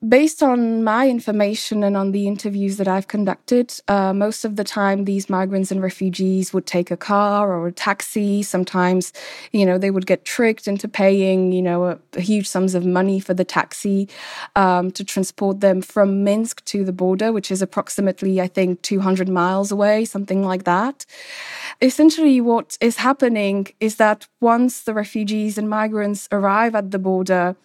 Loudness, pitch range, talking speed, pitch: -19 LUFS, 190-215 Hz, 180 wpm, 200 Hz